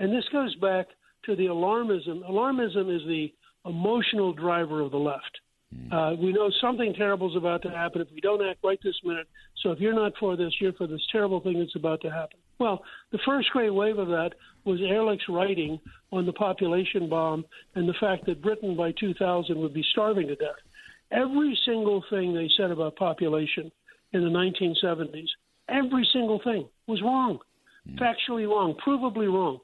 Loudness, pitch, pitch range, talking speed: -27 LUFS, 190 Hz, 170-215 Hz, 185 wpm